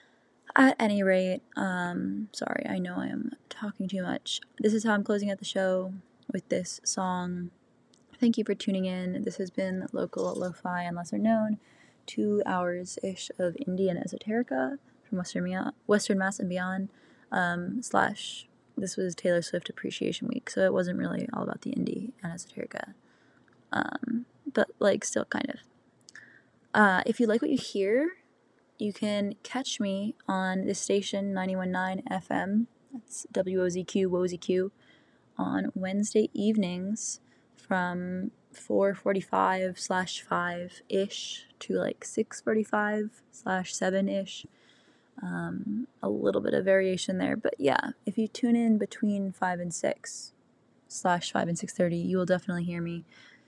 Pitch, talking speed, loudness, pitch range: 195 Hz, 145 wpm, -30 LUFS, 185-220 Hz